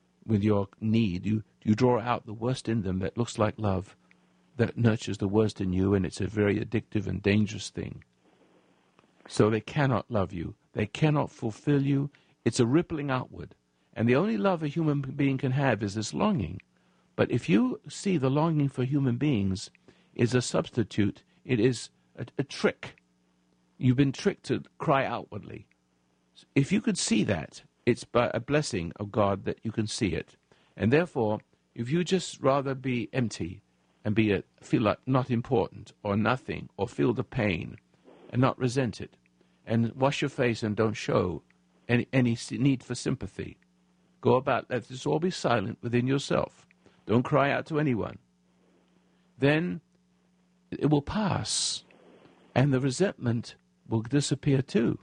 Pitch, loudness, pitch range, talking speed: 120 Hz, -28 LUFS, 100-140 Hz, 170 wpm